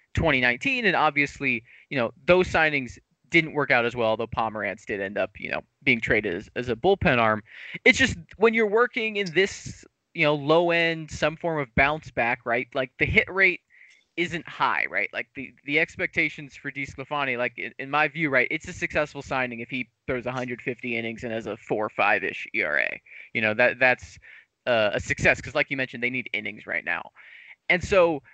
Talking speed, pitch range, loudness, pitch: 195 wpm, 125-170 Hz, -24 LUFS, 145 Hz